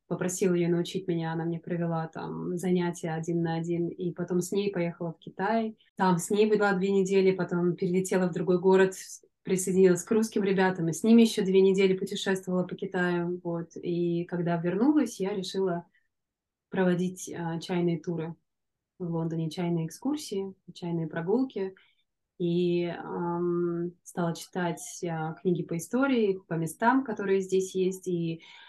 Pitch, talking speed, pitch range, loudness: 180 Hz, 155 wpm, 170-195 Hz, -28 LUFS